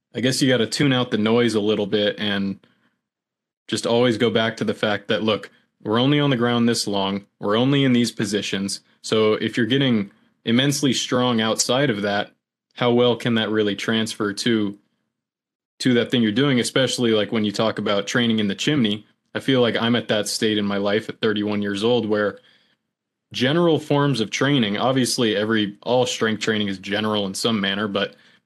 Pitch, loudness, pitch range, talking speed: 110 Hz, -21 LUFS, 105-125 Hz, 200 wpm